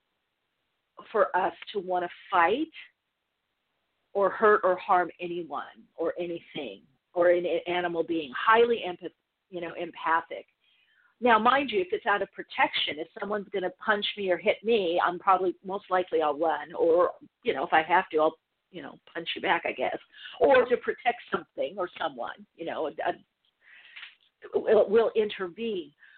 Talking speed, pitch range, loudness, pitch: 160 wpm, 175-235 Hz, -27 LUFS, 195 Hz